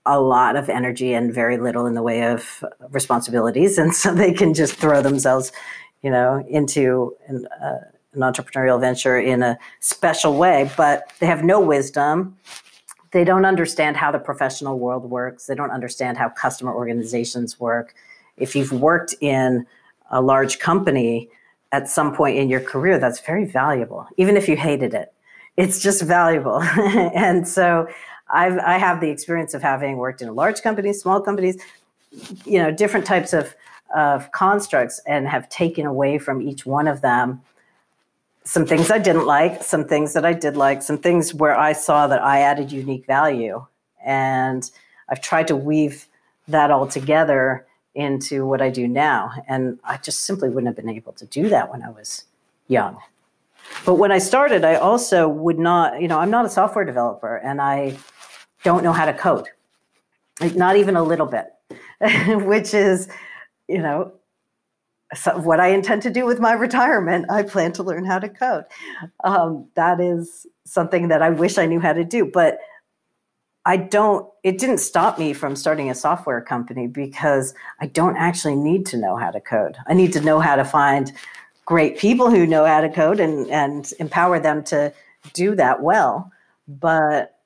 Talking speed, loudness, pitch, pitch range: 180 wpm, -19 LUFS, 150 Hz, 135-180 Hz